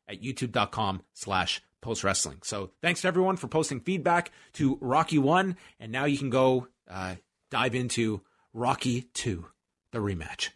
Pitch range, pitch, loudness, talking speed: 100-140 Hz, 125 Hz, -29 LUFS, 155 wpm